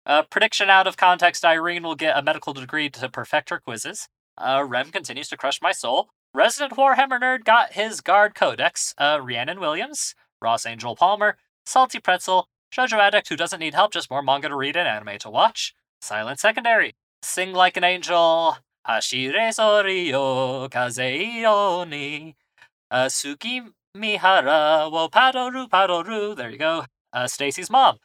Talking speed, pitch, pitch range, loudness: 160 wpm, 175 Hz, 140-210 Hz, -21 LUFS